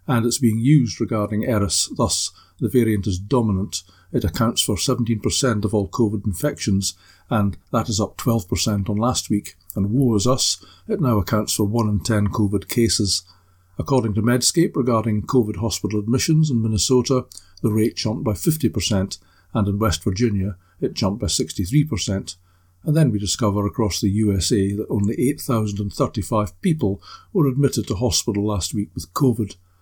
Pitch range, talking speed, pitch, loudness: 100-120 Hz, 165 wpm, 105 Hz, -21 LUFS